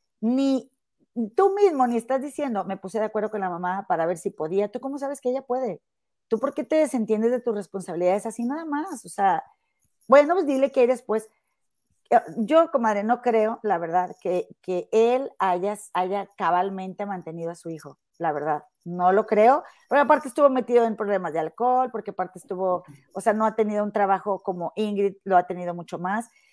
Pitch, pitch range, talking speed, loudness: 215 Hz, 185-255 Hz, 200 wpm, -24 LUFS